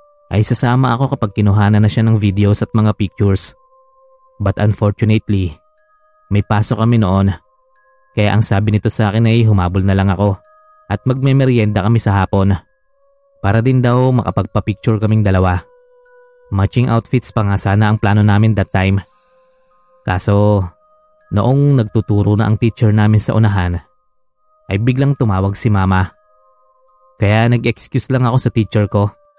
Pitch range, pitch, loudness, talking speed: 100-135 Hz, 110 Hz, -14 LUFS, 145 wpm